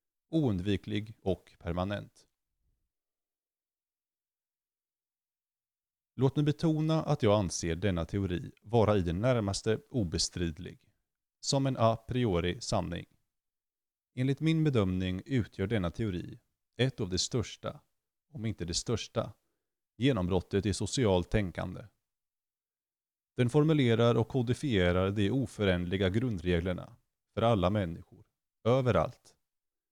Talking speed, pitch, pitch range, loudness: 100 wpm, 105 Hz, 90-125 Hz, -31 LUFS